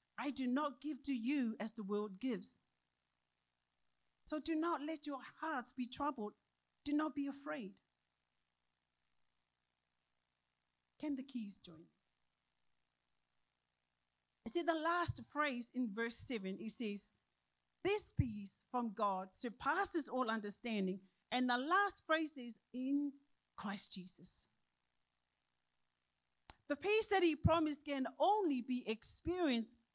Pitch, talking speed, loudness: 220 Hz, 120 wpm, -40 LUFS